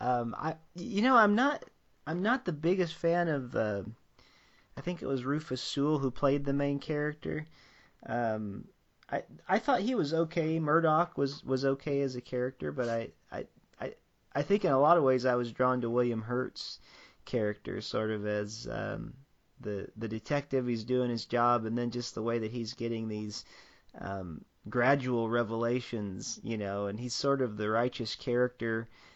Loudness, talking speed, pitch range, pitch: -32 LUFS, 180 wpm, 115-145 Hz, 125 Hz